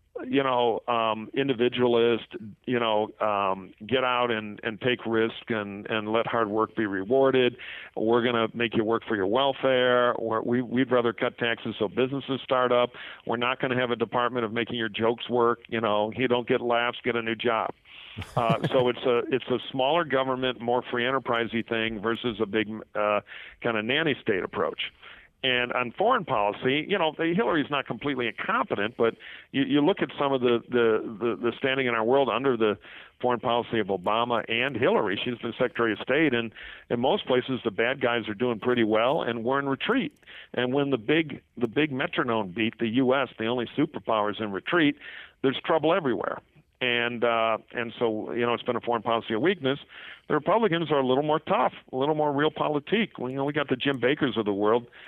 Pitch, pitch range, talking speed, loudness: 120 Hz, 115-130 Hz, 205 wpm, -26 LUFS